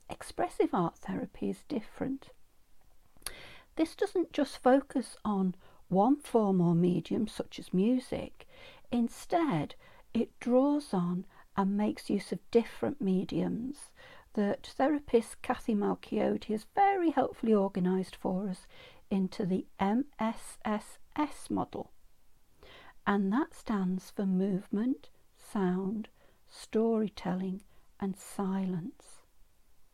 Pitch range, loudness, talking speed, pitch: 195-270 Hz, -32 LUFS, 100 wpm, 220 Hz